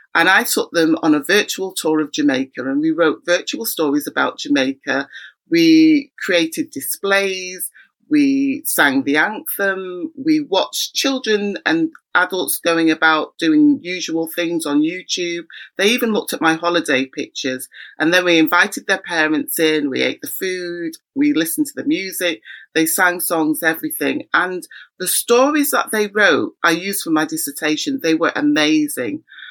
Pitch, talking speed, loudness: 185 Hz, 155 wpm, -17 LUFS